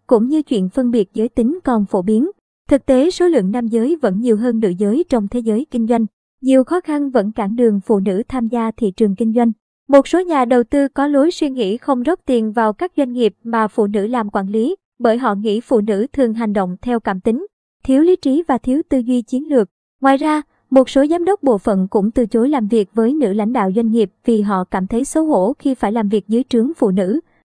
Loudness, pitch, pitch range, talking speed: -16 LUFS, 240 Hz, 220-275 Hz, 250 wpm